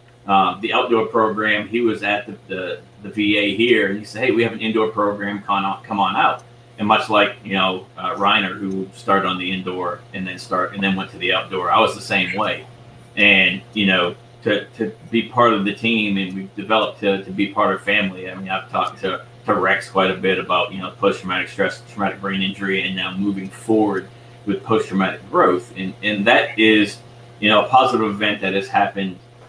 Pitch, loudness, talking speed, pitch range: 100 Hz, -19 LUFS, 220 wpm, 95-110 Hz